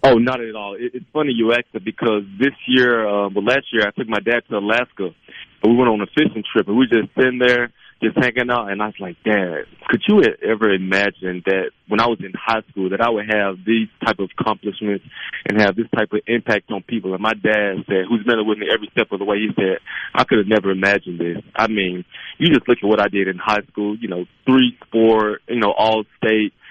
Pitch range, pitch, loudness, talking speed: 100-120 Hz, 110 Hz, -18 LUFS, 250 wpm